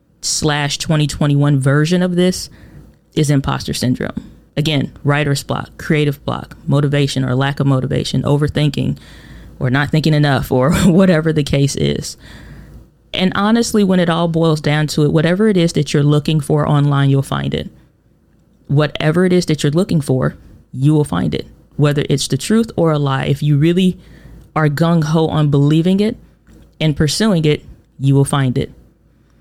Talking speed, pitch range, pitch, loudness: 165 wpm, 140-165 Hz, 150 Hz, -15 LUFS